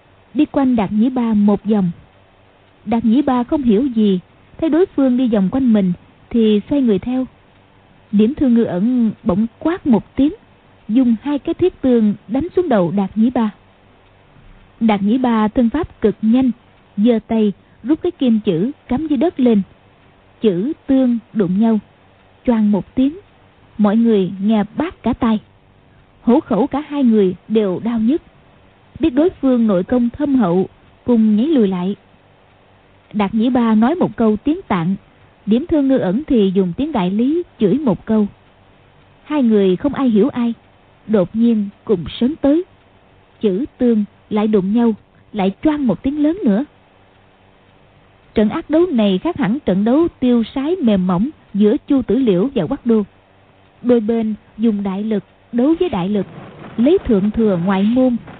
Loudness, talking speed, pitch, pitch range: -16 LUFS, 170 wpm, 225 Hz, 195-255 Hz